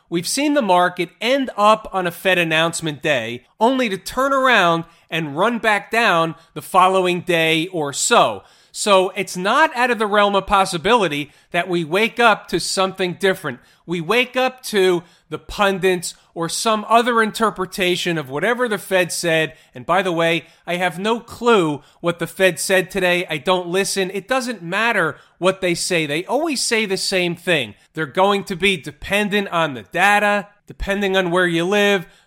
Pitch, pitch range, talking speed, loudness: 185 Hz, 170-205 Hz, 180 wpm, -18 LUFS